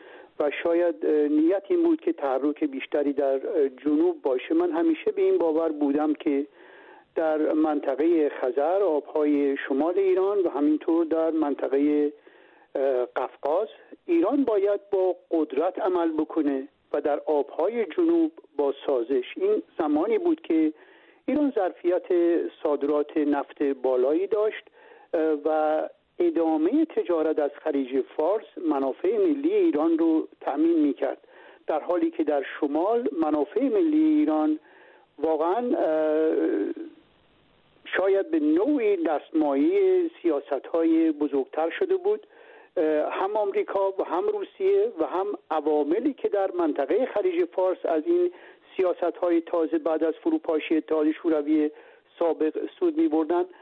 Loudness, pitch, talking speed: -25 LUFS, 215 Hz, 120 wpm